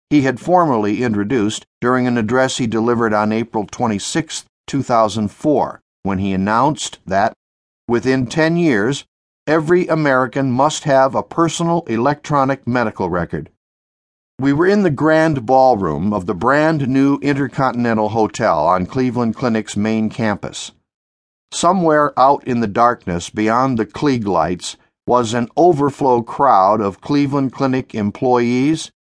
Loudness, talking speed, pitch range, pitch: -16 LUFS, 130 wpm, 105-140 Hz, 125 Hz